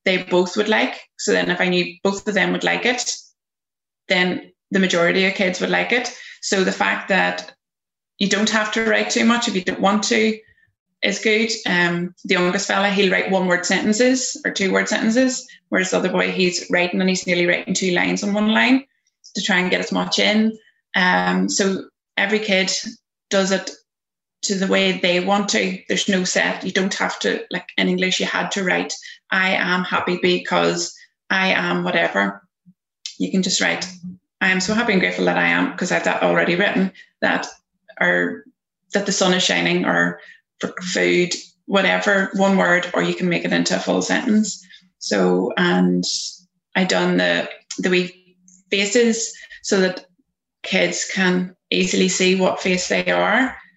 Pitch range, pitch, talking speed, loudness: 175-205 Hz, 185 Hz, 185 wpm, -19 LUFS